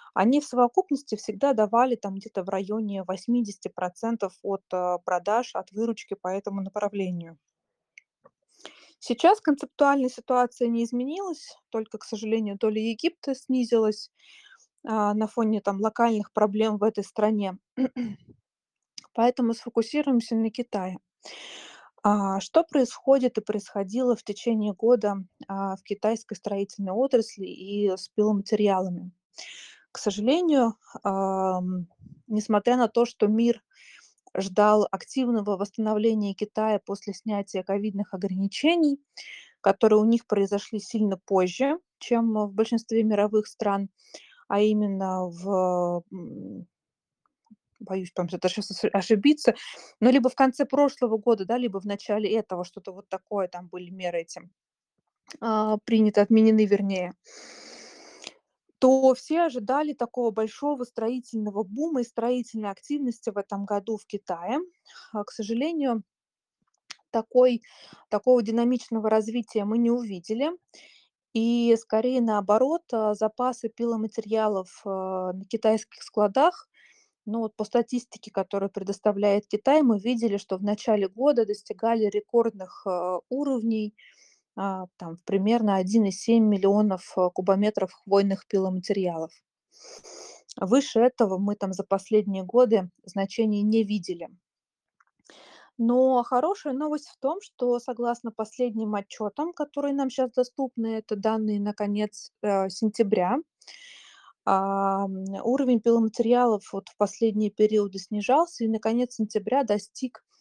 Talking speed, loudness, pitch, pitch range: 115 wpm, -26 LUFS, 220 Hz, 200-245 Hz